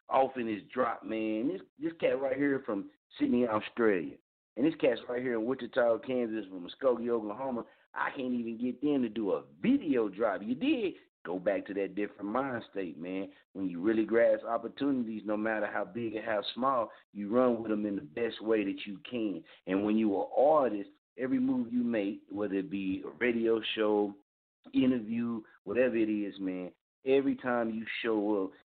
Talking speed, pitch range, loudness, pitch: 190 wpm, 105-135 Hz, -32 LUFS, 115 Hz